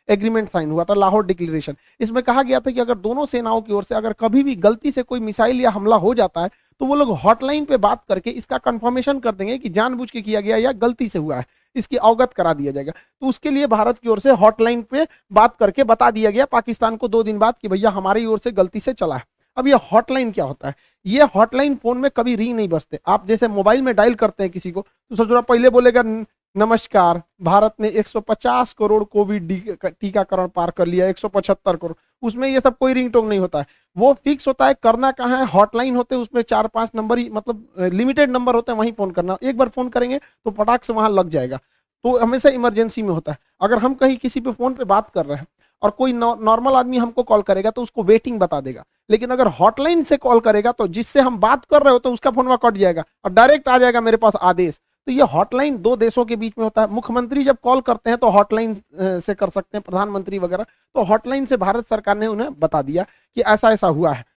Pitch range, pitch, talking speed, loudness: 200-250 Hz, 225 Hz, 240 wpm, -18 LUFS